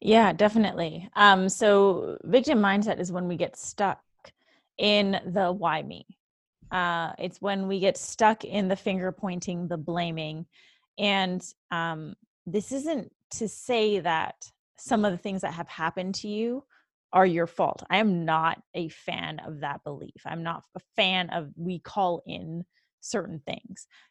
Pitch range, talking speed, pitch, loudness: 170-205 Hz, 160 wpm, 185 Hz, -27 LUFS